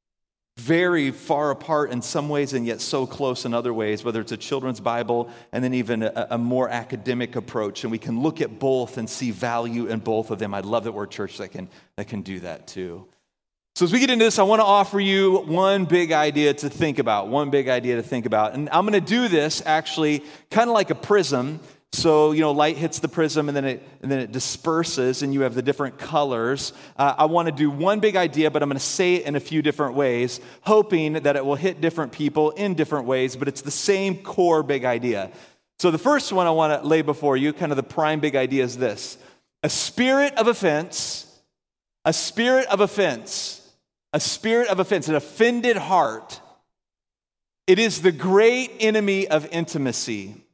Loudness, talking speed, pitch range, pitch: -22 LUFS, 215 wpm, 125-175 Hz, 150 Hz